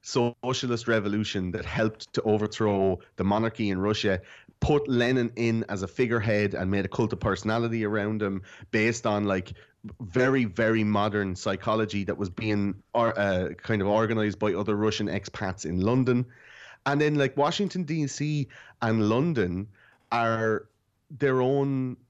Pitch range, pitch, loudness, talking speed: 100-120 Hz, 110 Hz, -27 LUFS, 145 wpm